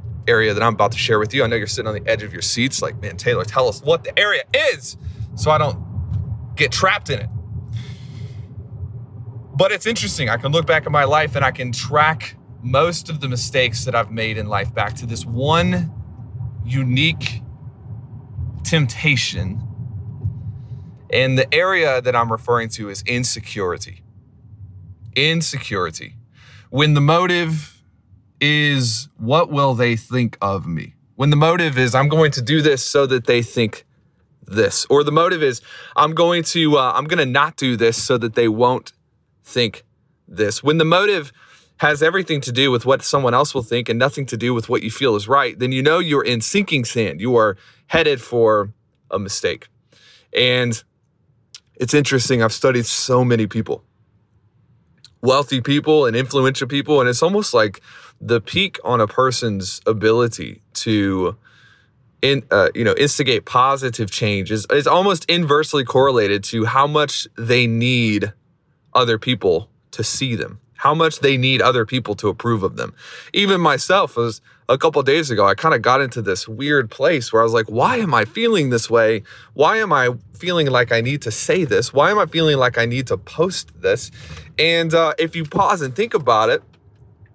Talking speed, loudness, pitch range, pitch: 180 wpm, -18 LUFS, 115-145 Hz, 125 Hz